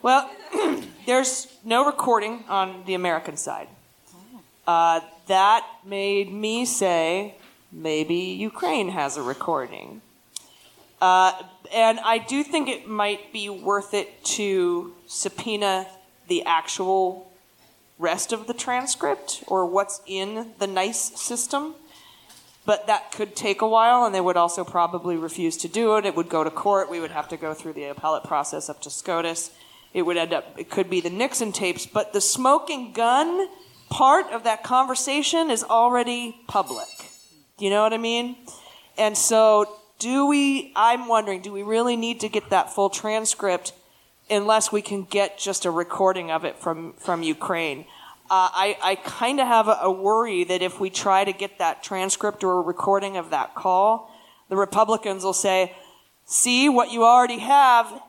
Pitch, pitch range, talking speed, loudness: 200 Hz, 185-235 Hz, 165 wpm, -22 LUFS